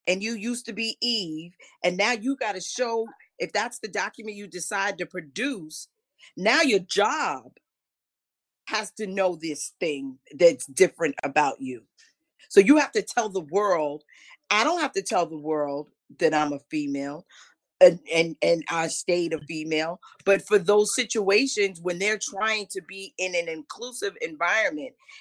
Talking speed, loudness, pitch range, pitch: 165 wpm, -25 LUFS, 165-230 Hz, 195 Hz